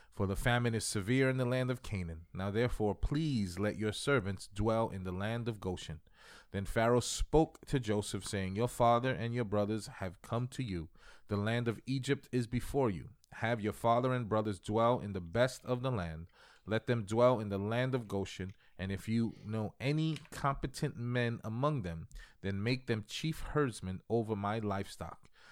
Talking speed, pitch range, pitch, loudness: 190 wpm, 100-125 Hz, 115 Hz, -35 LUFS